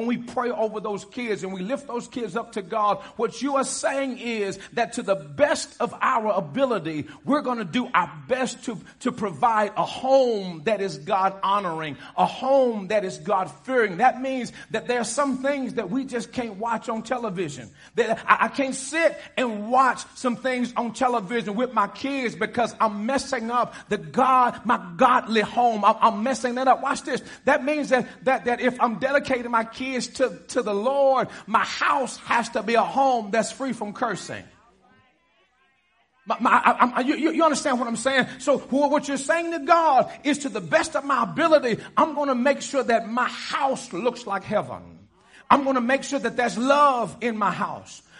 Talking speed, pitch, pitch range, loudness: 200 wpm, 245 Hz, 215-265 Hz, -23 LUFS